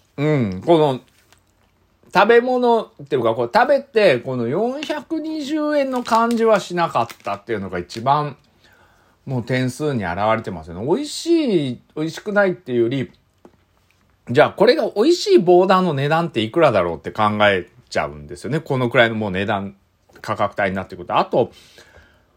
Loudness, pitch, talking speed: -19 LUFS, 135 Hz, 325 characters per minute